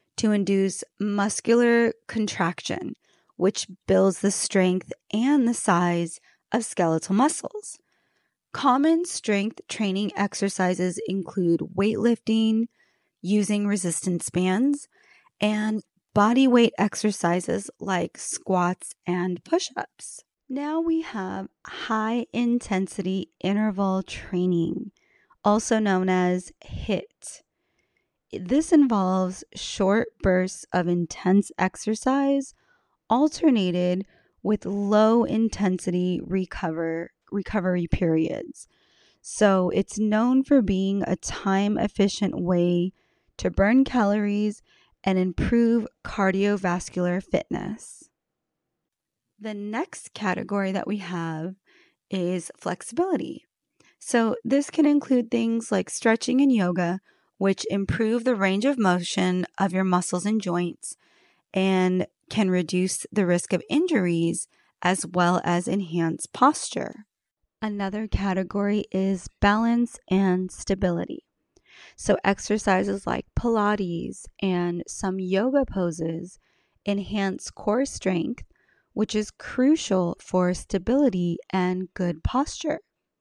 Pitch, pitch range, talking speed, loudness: 200 Hz, 185-230 Hz, 100 wpm, -24 LUFS